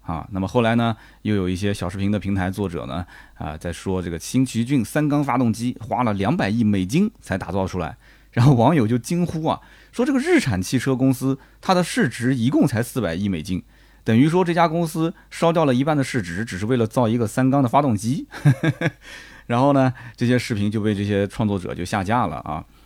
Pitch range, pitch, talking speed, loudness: 100-140 Hz, 120 Hz, 315 characters per minute, -21 LUFS